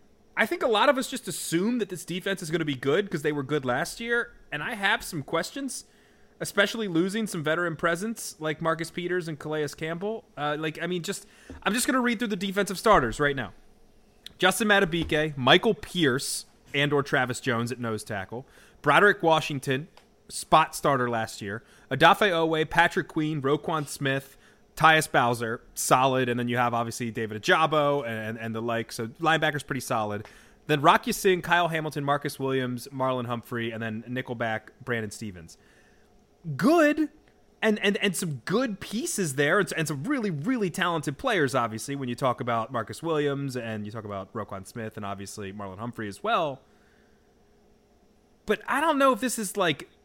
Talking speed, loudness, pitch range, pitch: 180 wpm, -26 LUFS, 120-185 Hz, 150 Hz